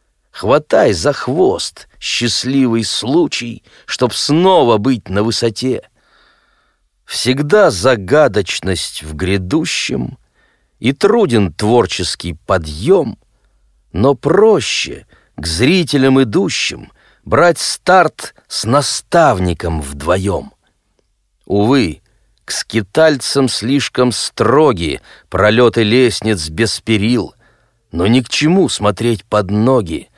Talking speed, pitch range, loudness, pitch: 85 wpm, 100-130 Hz, -14 LUFS, 115 Hz